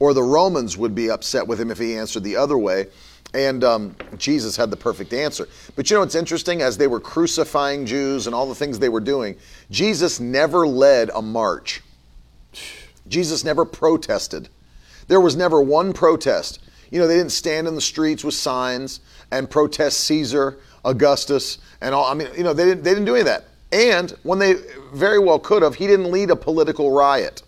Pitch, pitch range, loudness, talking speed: 145 Hz, 125-170 Hz, -19 LUFS, 200 wpm